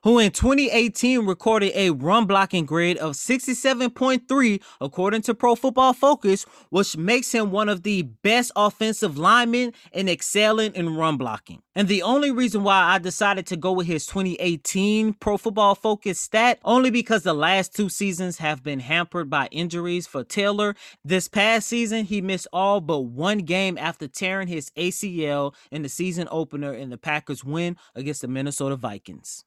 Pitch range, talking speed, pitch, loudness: 165-220 Hz, 170 wpm, 195 Hz, -22 LUFS